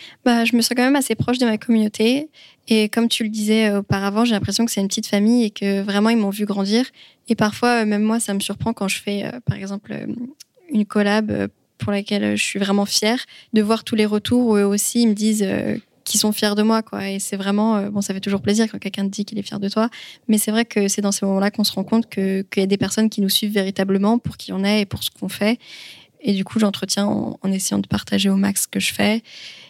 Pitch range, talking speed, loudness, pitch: 200-225 Hz, 265 wpm, -20 LUFS, 210 Hz